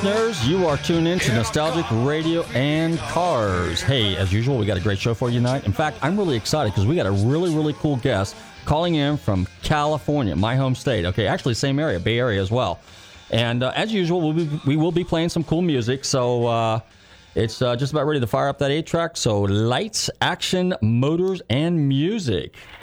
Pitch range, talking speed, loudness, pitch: 110-160 Hz, 215 wpm, -21 LUFS, 135 Hz